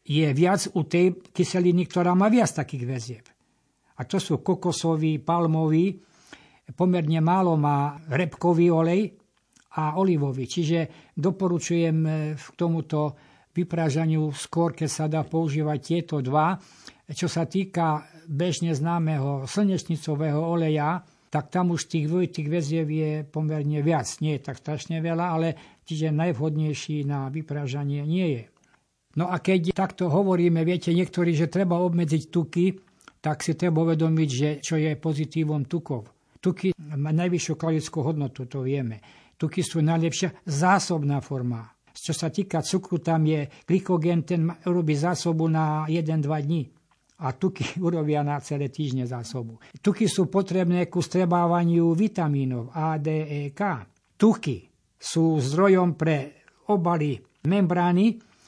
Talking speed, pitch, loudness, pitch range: 130 wpm, 160 Hz, -25 LUFS, 150-175 Hz